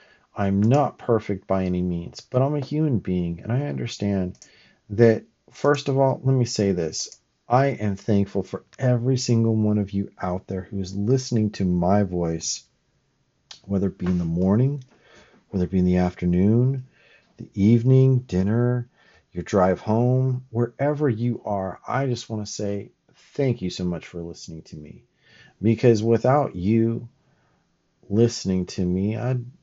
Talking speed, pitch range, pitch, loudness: 160 wpm, 95-125 Hz, 105 Hz, -23 LUFS